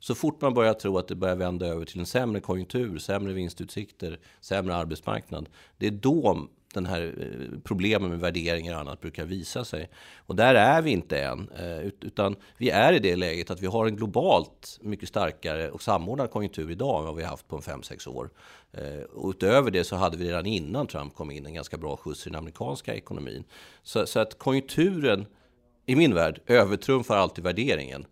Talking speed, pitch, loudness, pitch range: 200 wpm, 95 Hz, -27 LUFS, 85-105 Hz